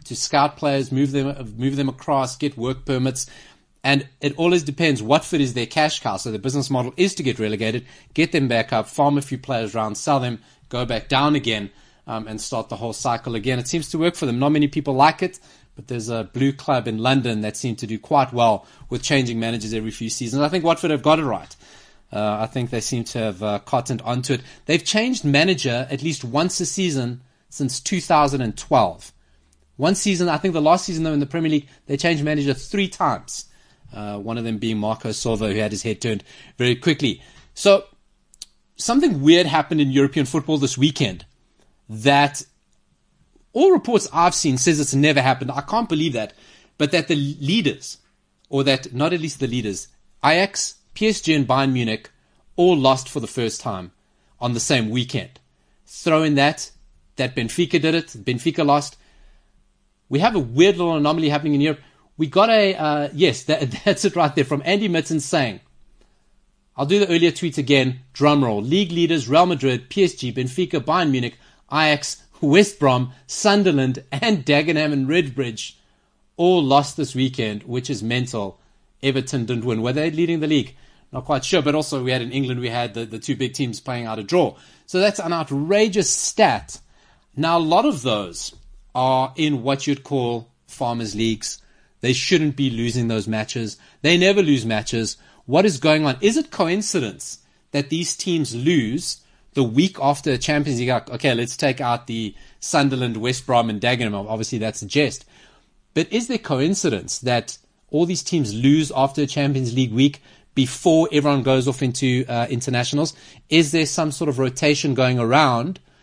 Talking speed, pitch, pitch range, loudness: 190 wpm, 140 Hz, 120-155 Hz, -20 LUFS